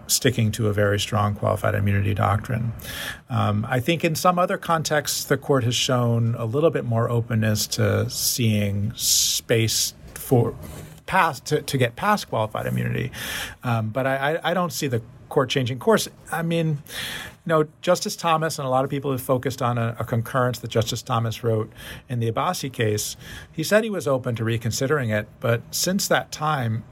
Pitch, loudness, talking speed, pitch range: 125 Hz, -23 LUFS, 185 wpm, 110-150 Hz